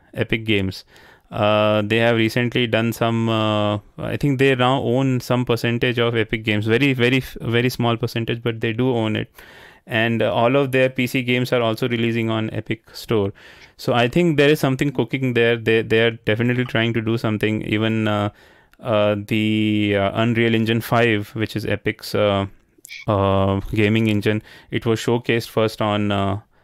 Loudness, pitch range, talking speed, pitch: -20 LUFS, 105-120 Hz, 180 wpm, 115 Hz